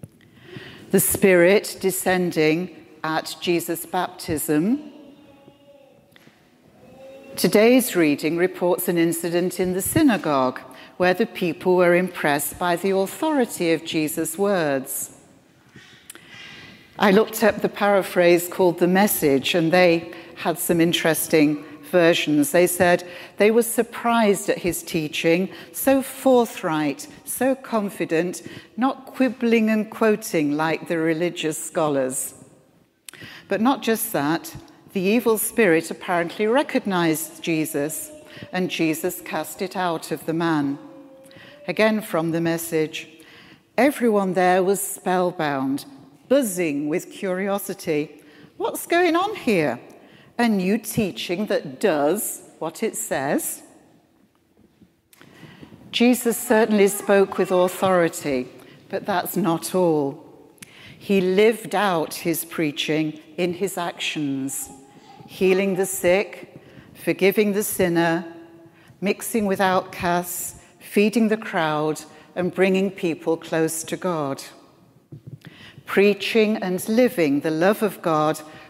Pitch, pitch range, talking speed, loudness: 180 Hz, 160-205 Hz, 110 wpm, -21 LUFS